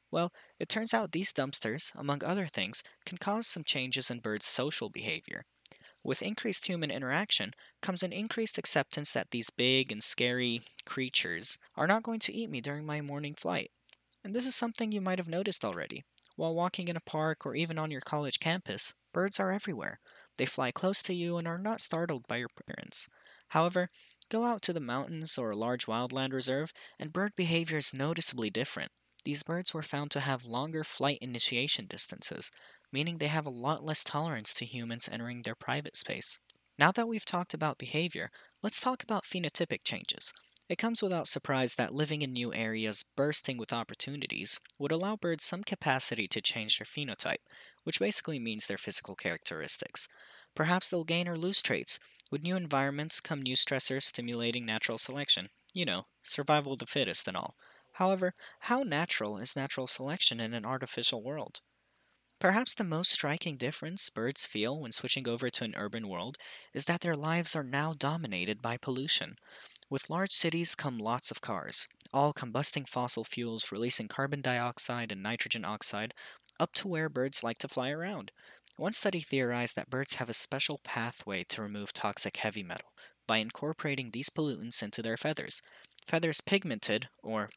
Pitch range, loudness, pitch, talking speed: 125-175 Hz, -29 LUFS, 145 Hz, 175 wpm